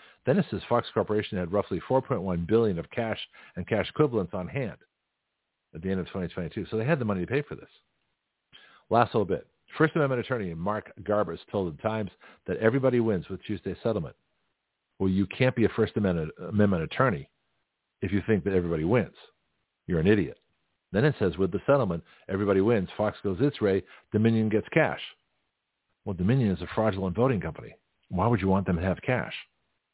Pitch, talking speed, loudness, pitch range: 100 Hz, 190 wpm, -28 LUFS, 95-115 Hz